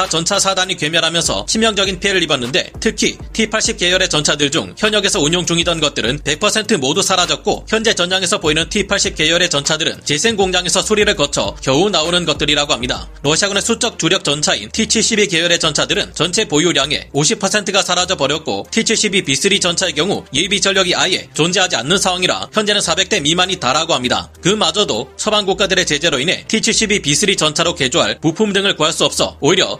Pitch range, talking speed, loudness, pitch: 160-205 Hz, 395 characters per minute, -14 LUFS, 185 Hz